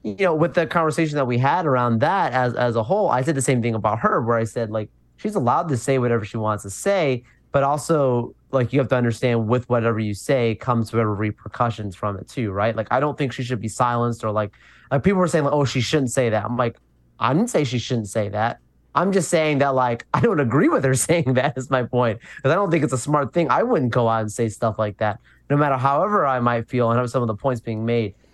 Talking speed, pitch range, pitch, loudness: 270 wpm, 110-135 Hz, 125 Hz, -21 LUFS